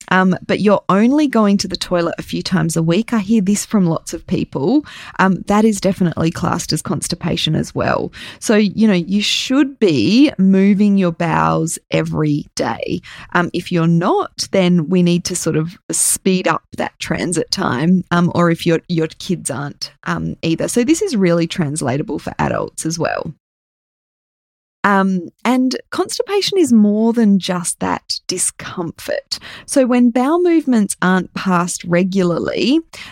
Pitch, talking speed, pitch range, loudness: 185 Hz, 160 wpm, 170-220 Hz, -16 LUFS